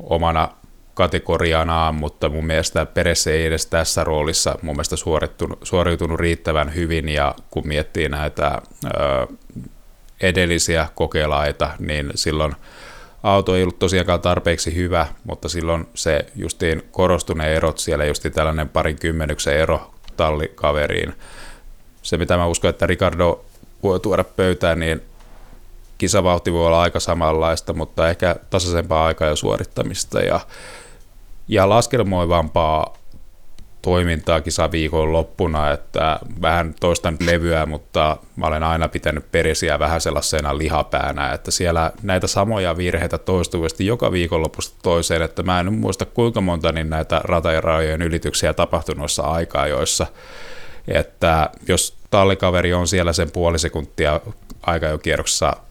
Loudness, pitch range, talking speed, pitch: -19 LUFS, 80-90 Hz, 125 wpm, 85 Hz